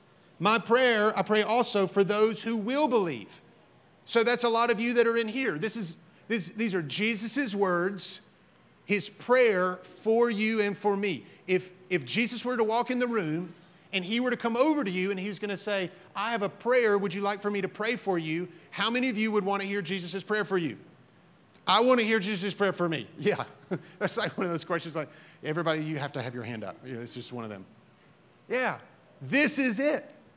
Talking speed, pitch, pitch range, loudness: 230 wpm, 200 Hz, 175-230 Hz, -28 LUFS